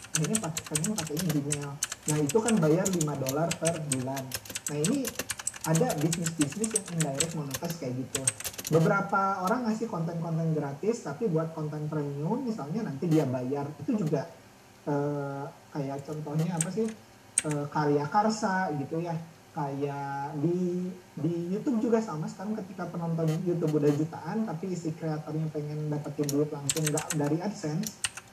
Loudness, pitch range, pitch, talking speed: -30 LUFS, 145-185 Hz, 160 Hz, 145 wpm